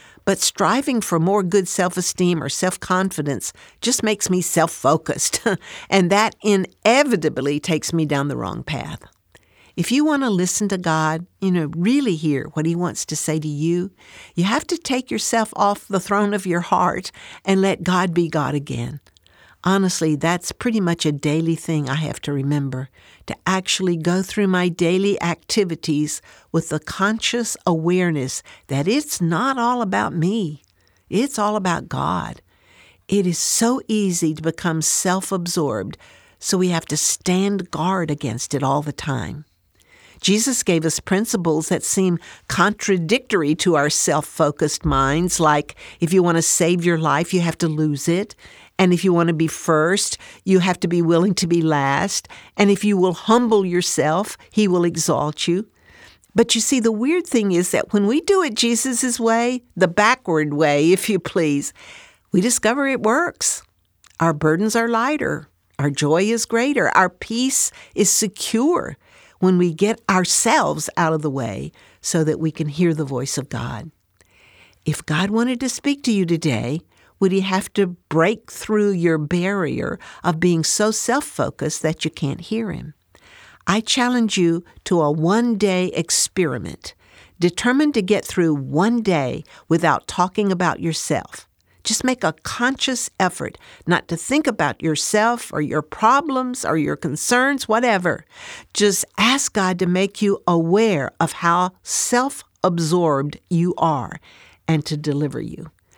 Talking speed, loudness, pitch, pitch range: 165 wpm, -19 LUFS, 180 Hz, 160-210 Hz